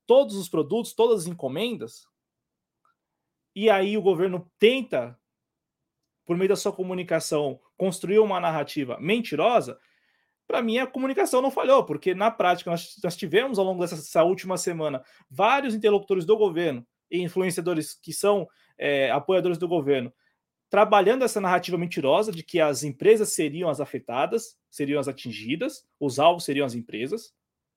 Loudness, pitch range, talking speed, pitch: -24 LUFS, 160-215 Hz, 145 wpm, 185 Hz